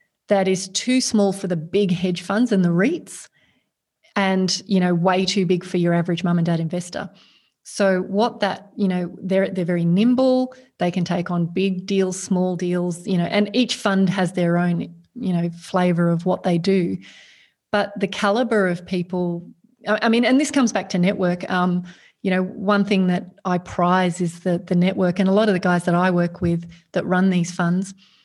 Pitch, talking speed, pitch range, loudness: 185 Hz, 205 wpm, 180-200 Hz, -21 LUFS